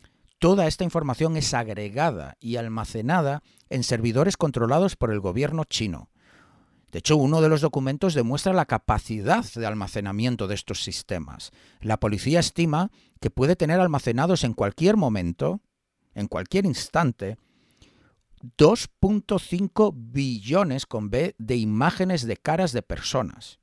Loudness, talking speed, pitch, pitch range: -24 LUFS, 130 wpm, 125 Hz, 110-165 Hz